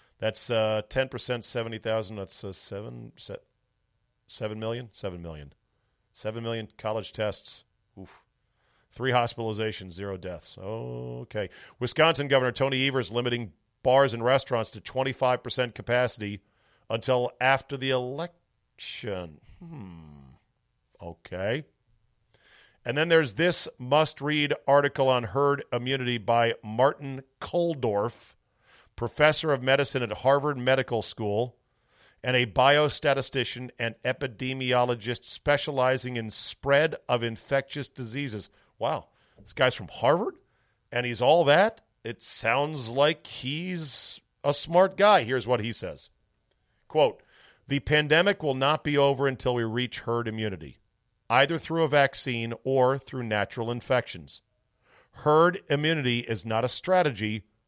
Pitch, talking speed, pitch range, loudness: 125 Hz, 120 wpm, 110-140 Hz, -27 LUFS